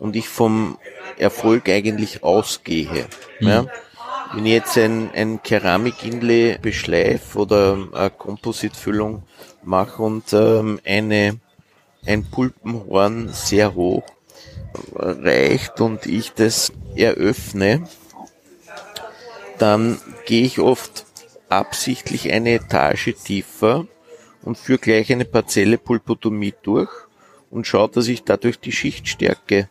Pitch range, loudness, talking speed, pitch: 100-115 Hz, -19 LUFS, 105 wpm, 110 Hz